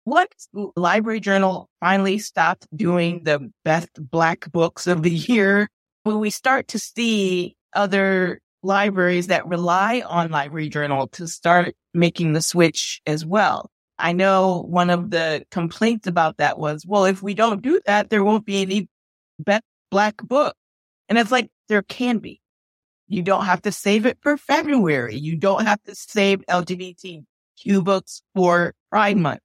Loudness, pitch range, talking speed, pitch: -20 LUFS, 170-210 Hz, 160 wpm, 190 Hz